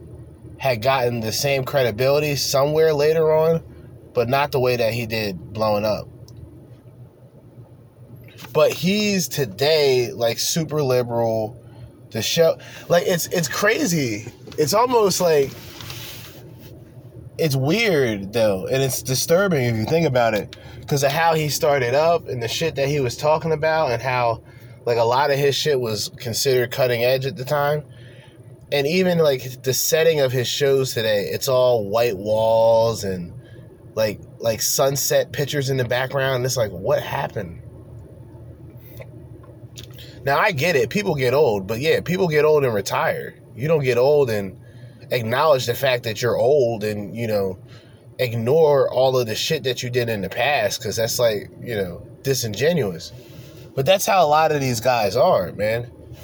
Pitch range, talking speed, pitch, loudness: 115-145 Hz, 165 wpm, 125 Hz, -20 LUFS